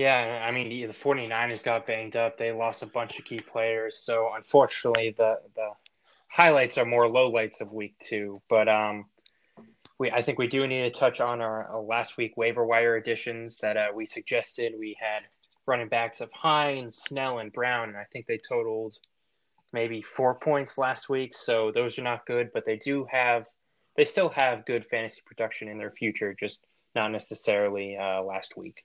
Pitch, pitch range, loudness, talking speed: 115 Hz, 110-130 Hz, -27 LUFS, 190 wpm